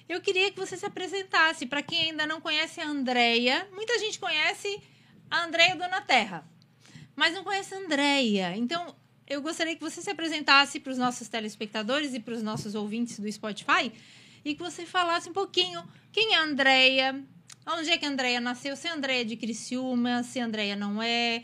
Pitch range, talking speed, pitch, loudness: 240-340 Hz, 195 wpm, 285 Hz, -27 LUFS